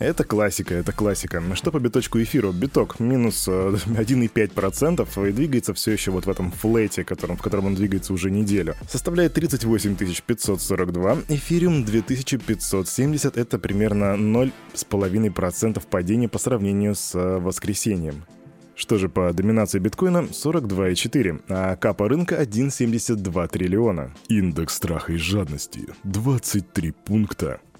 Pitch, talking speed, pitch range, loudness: 105 Hz, 120 wpm, 95-120 Hz, -22 LUFS